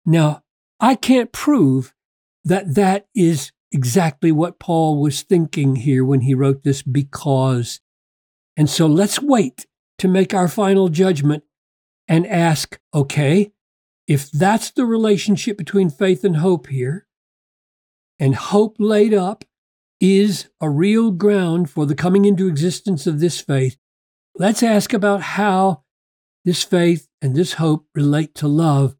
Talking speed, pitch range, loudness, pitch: 140 wpm, 145-200 Hz, -17 LUFS, 170 Hz